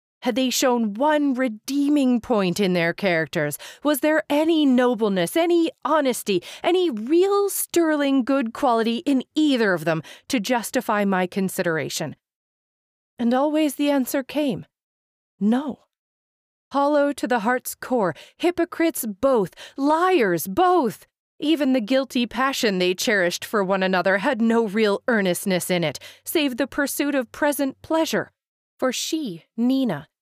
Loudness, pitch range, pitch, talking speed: -22 LUFS, 210-295 Hz, 260 Hz, 135 wpm